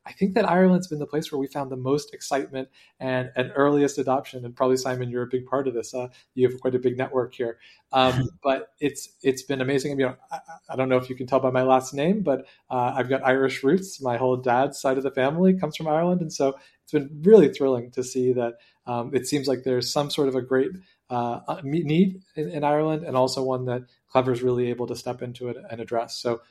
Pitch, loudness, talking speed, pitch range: 130 Hz, -24 LUFS, 250 wpm, 125-145 Hz